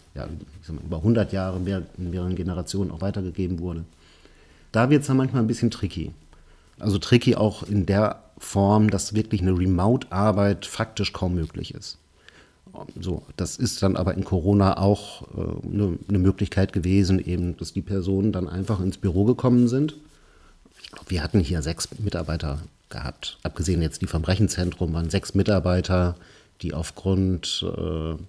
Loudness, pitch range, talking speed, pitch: -24 LUFS, 85-100 Hz, 165 wpm, 95 Hz